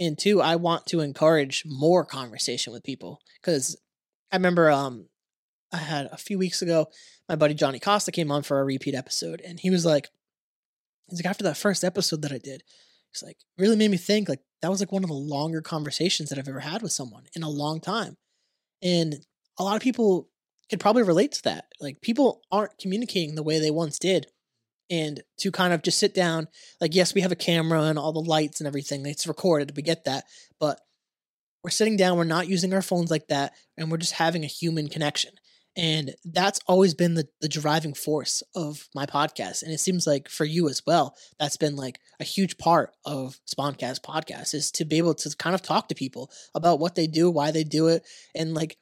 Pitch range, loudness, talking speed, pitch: 150-180 Hz, -25 LUFS, 220 wpm, 160 Hz